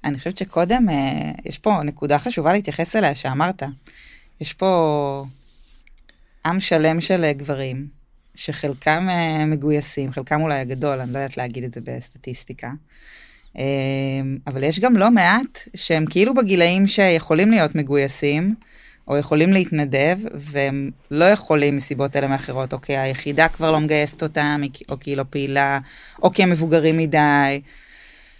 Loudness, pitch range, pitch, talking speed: -19 LUFS, 140-170 Hz, 150 Hz, 145 wpm